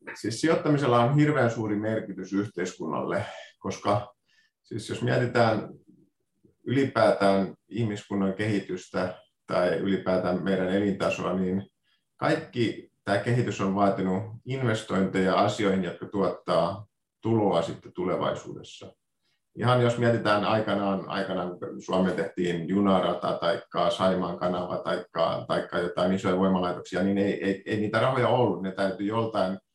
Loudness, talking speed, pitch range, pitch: -27 LUFS, 115 wpm, 95-110 Hz, 100 Hz